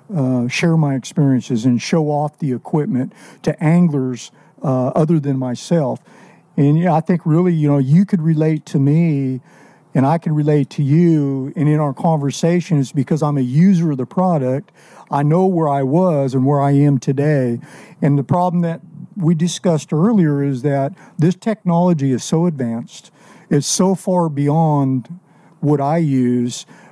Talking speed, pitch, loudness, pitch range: 170 wpm, 150 Hz, -17 LUFS, 140-170 Hz